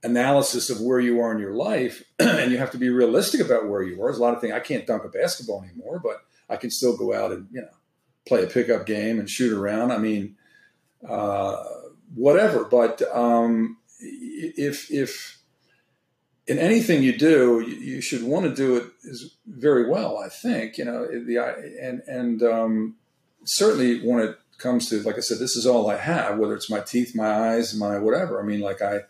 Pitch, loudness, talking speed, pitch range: 120 Hz, -23 LUFS, 210 wpm, 110-125 Hz